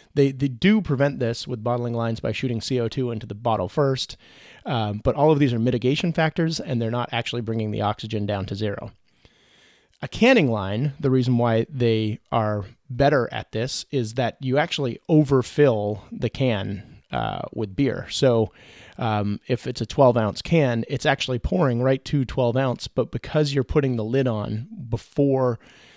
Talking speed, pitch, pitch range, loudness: 180 wpm, 120 Hz, 110-135 Hz, -23 LUFS